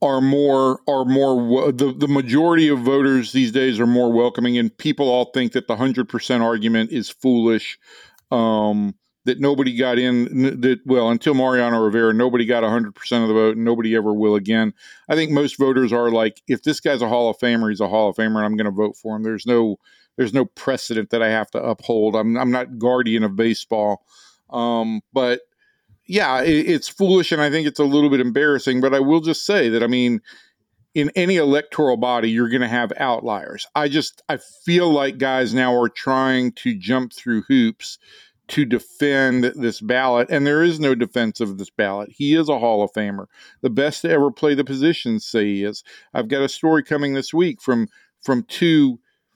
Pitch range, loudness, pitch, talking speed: 115-145 Hz, -19 LUFS, 125 Hz, 205 wpm